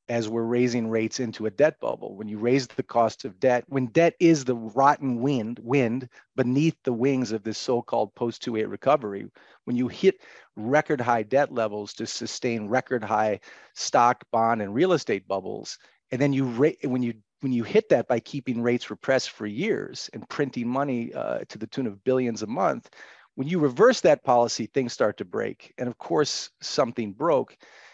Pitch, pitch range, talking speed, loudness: 125 Hz, 115-135 Hz, 190 wpm, -25 LUFS